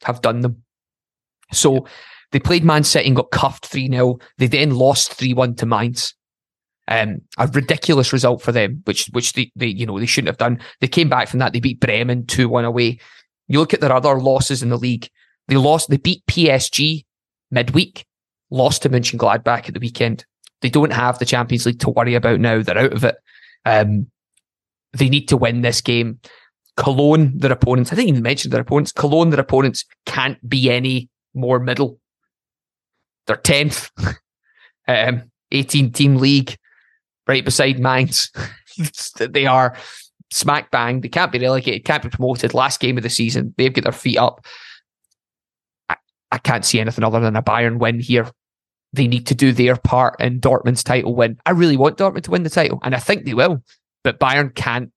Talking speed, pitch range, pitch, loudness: 185 wpm, 120-140 Hz, 130 Hz, -17 LUFS